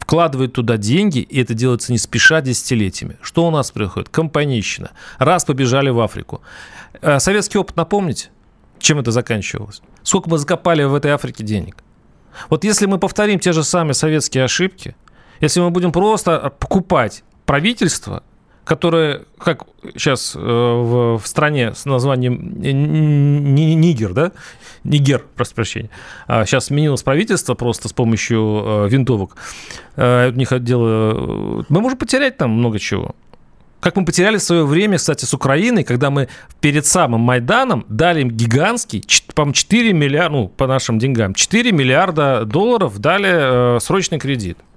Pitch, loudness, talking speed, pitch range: 140 Hz, -16 LUFS, 130 wpm, 120-170 Hz